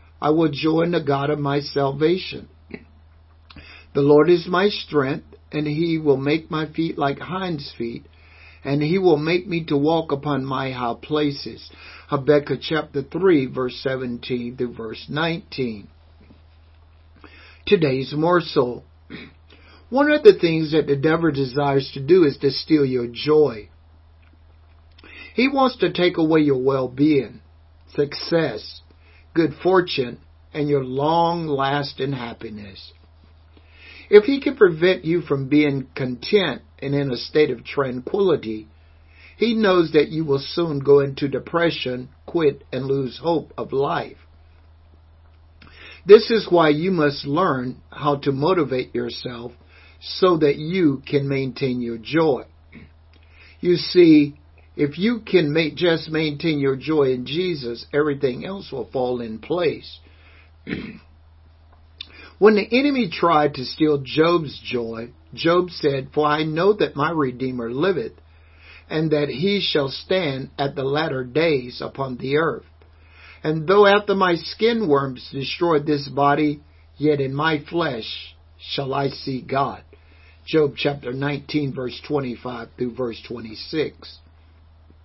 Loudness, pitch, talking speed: -21 LUFS, 135 Hz, 135 wpm